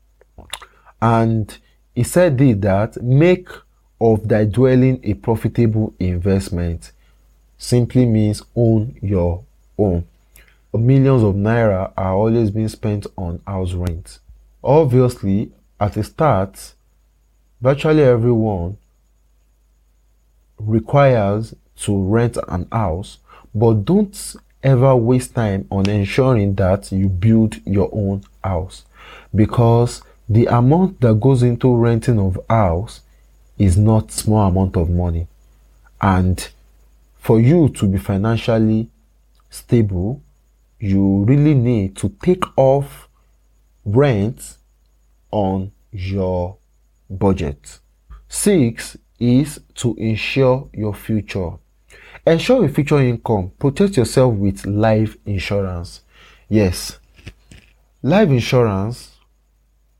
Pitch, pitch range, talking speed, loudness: 105 Hz, 95-120 Hz, 100 wpm, -17 LUFS